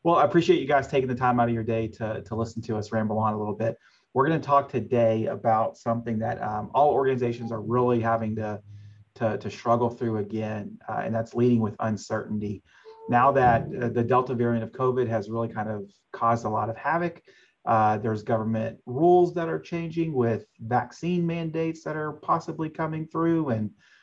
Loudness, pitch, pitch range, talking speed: -26 LUFS, 115 Hz, 110-140 Hz, 200 wpm